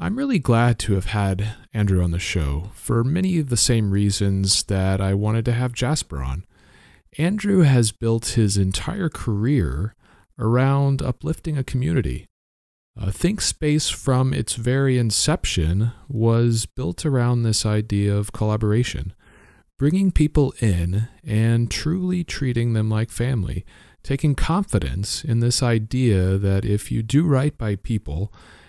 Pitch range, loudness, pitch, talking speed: 100-135 Hz, -21 LUFS, 115 Hz, 140 wpm